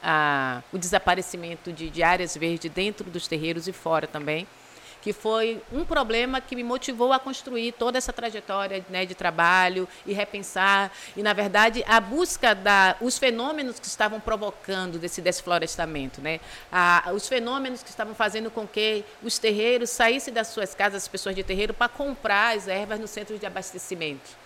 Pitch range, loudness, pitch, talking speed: 180-230 Hz, -25 LUFS, 205 Hz, 170 wpm